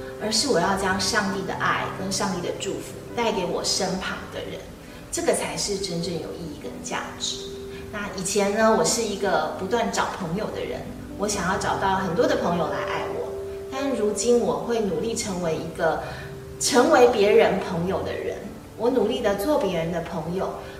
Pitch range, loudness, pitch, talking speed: 165-220 Hz, -24 LUFS, 200 Hz, 265 characters per minute